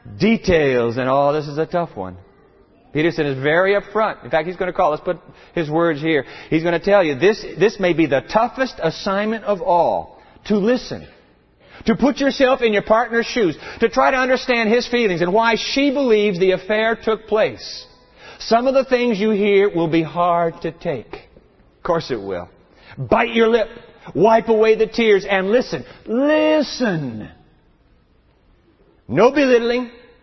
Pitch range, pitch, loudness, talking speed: 170-235 Hz, 210 Hz, -18 LUFS, 175 wpm